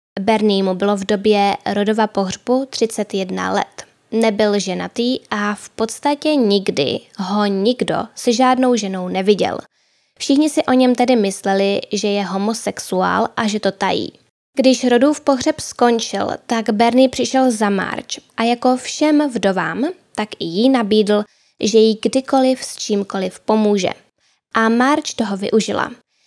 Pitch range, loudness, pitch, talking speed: 205-255 Hz, -17 LUFS, 225 Hz, 140 wpm